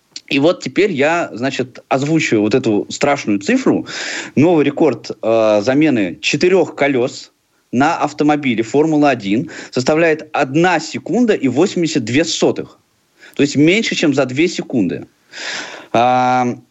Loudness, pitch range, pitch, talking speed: -15 LUFS, 125-155 Hz, 140 Hz, 120 wpm